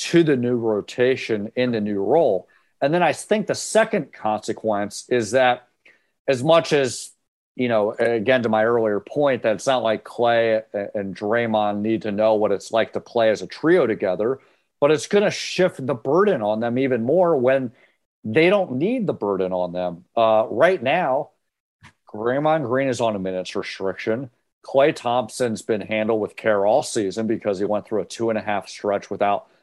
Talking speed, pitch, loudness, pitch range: 190 wpm, 115 Hz, -21 LUFS, 105-130 Hz